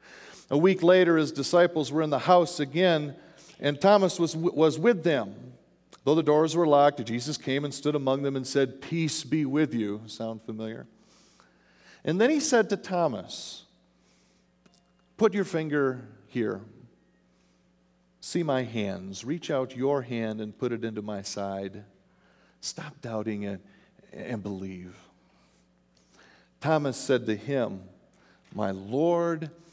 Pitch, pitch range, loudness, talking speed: 135 Hz, 105-160 Hz, -27 LUFS, 140 wpm